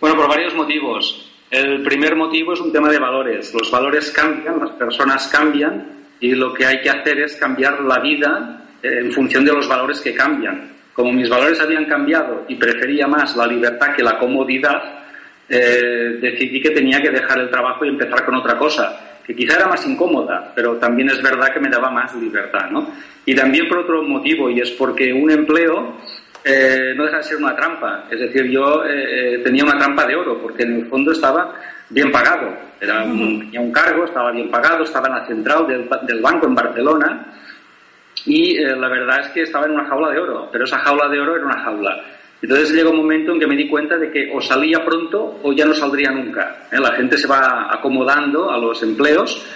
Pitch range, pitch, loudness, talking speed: 125-155 Hz, 140 Hz, -16 LUFS, 210 wpm